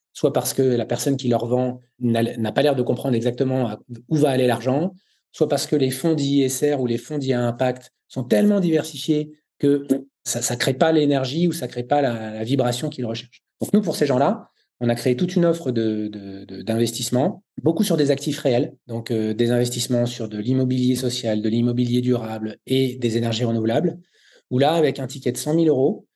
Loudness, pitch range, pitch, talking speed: -22 LUFS, 120-145 Hz, 125 Hz, 215 wpm